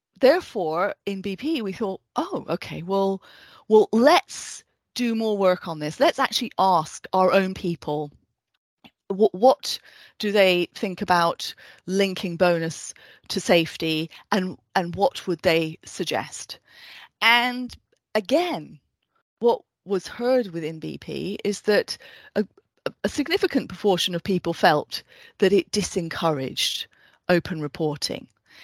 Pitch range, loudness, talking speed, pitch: 175-220 Hz, -23 LUFS, 120 wpm, 195 Hz